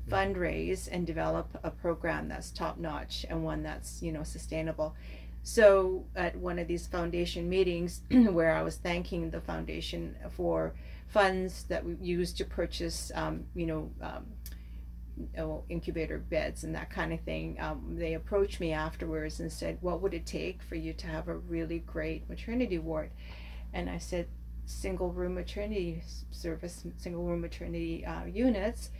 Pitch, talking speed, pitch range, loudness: 165 Hz, 160 wpm, 150-180 Hz, -34 LUFS